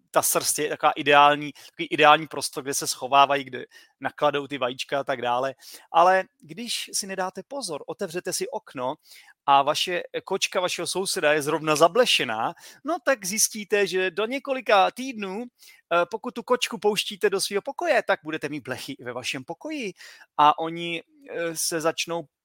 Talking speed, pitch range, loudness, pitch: 155 wpm, 150-210 Hz, -24 LUFS, 170 Hz